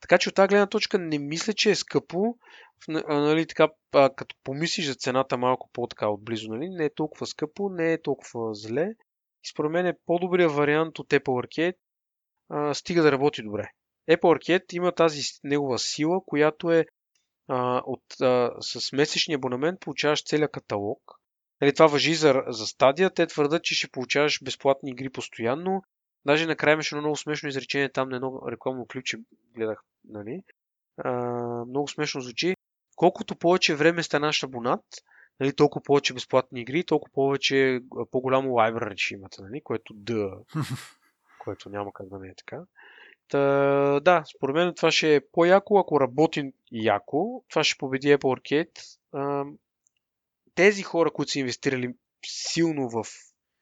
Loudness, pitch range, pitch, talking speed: -25 LUFS, 125-165 Hz, 145 Hz, 160 wpm